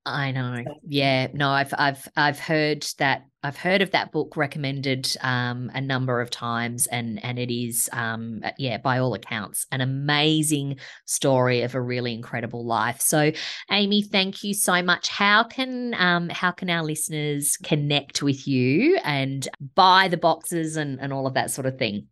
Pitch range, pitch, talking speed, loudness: 125-165 Hz, 140 Hz, 175 wpm, -23 LUFS